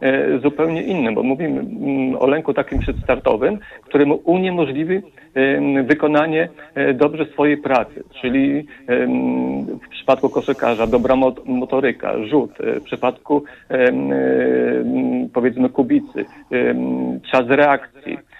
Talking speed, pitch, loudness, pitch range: 90 wpm, 135 Hz, -18 LUFS, 120-145 Hz